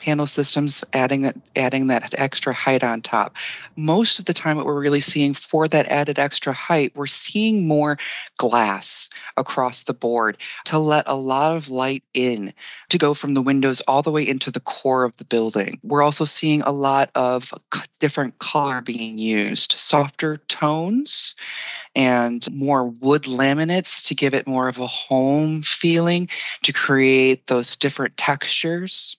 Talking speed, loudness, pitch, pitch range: 165 wpm, -20 LUFS, 140 Hz, 130-150 Hz